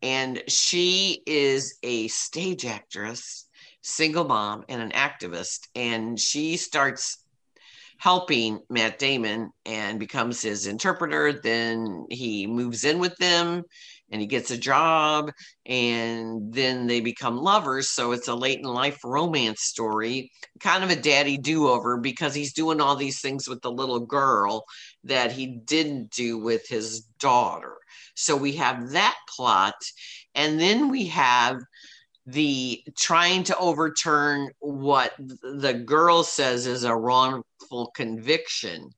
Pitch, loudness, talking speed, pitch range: 130 Hz, -24 LUFS, 135 wpm, 115-150 Hz